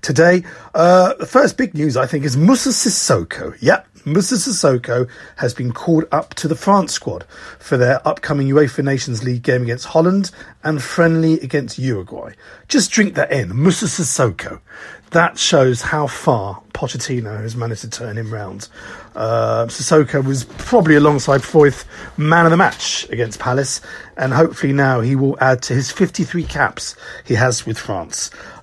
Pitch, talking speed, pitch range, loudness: 145 Hz, 165 wpm, 125-170 Hz, -16 LUFS